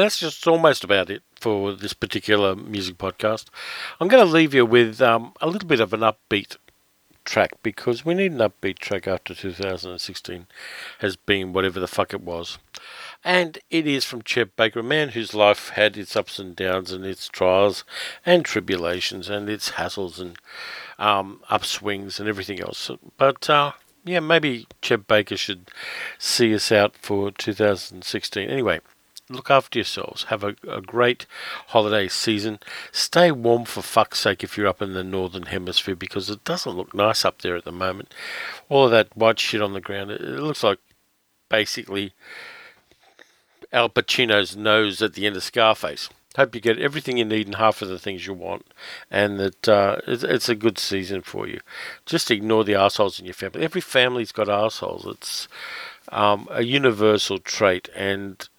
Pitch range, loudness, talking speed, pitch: 95-115 Hz, -22 LUFS, 175 wpm, 105 Hz